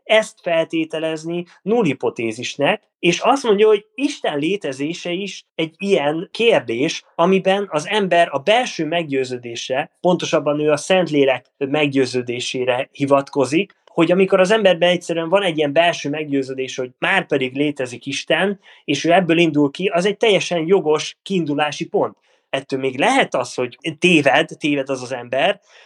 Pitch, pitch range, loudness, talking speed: 165 Hz, 140-185 Hz, -18 LUFS, 140 wpm